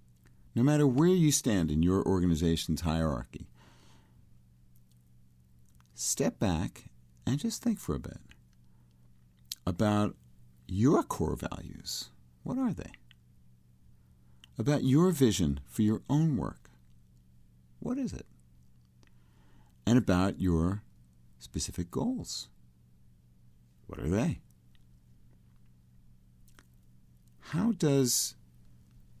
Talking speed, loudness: 90 wpm, -30 LUFS